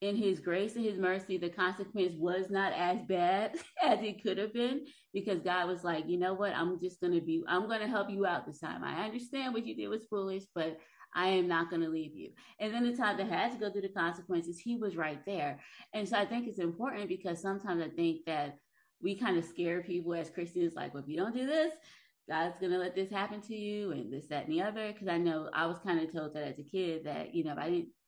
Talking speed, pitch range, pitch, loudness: 265 wpm, 170-210 Hz, 185 Hz, -35 LUFS